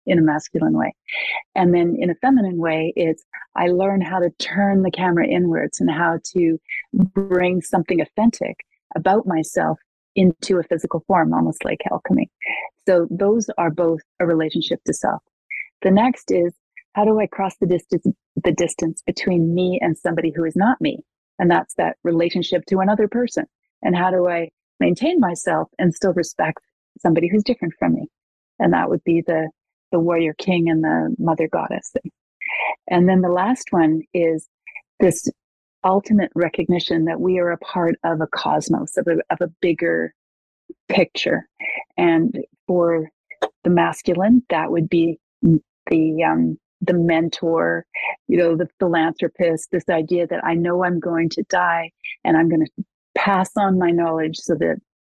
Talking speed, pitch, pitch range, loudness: 165 wpm, 175 Hz, 165-190 Hz, -20 LUFS